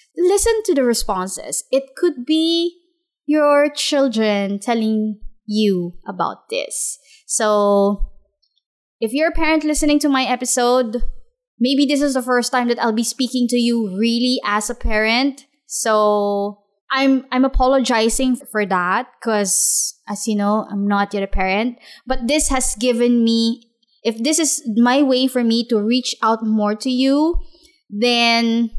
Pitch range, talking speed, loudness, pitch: 215-275 Hz, 150 wpm, -18 LUFS, 245 Hz